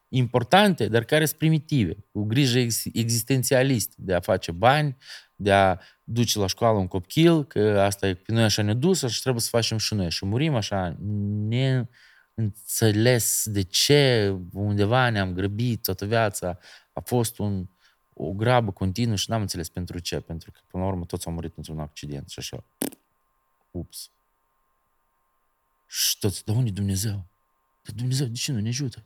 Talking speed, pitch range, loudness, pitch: 165 wpm, 95-130 Hz, -24 LUFS, 110 Hz